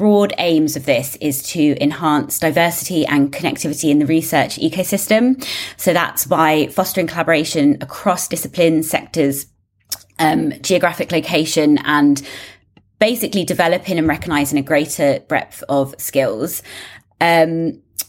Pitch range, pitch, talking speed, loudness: 145-175 Hz, 160 Hz, 120 wpm, -16 LUFS